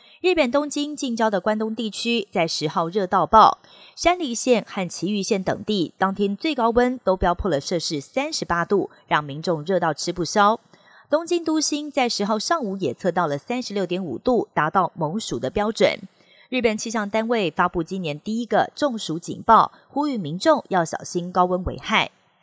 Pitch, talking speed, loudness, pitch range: 205 Hz, 275 characters per minute, -22 LUFS, 175-240 Hz